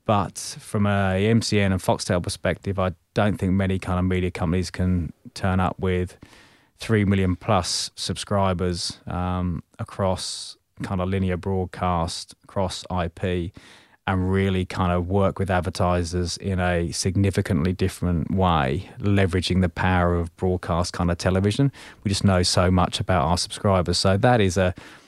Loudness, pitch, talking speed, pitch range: -23 LUFS, 95 Hz, 150 wpm, 90-100 Hz